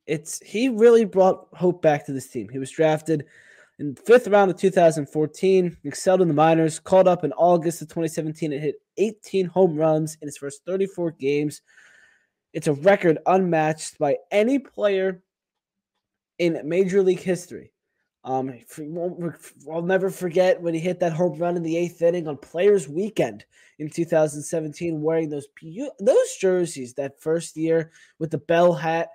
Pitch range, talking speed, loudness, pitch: 155-185 Hz, 165 wpm, -22 LUFS, 170 Hz